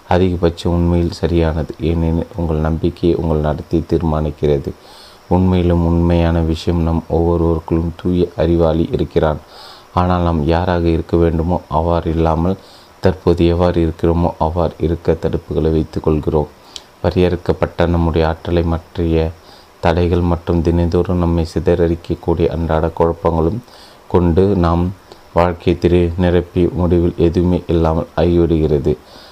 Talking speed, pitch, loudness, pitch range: 100 wpm, 85 Hz, -16 LUFS, 80-90 Hz